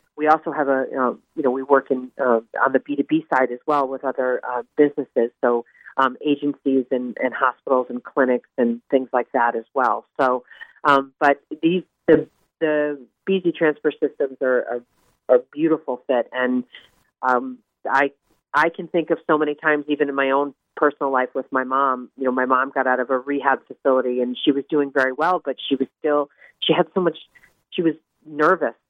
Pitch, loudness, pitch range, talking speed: 135 Hz, -21 LUFS, 130-150 Hz, 200 wpm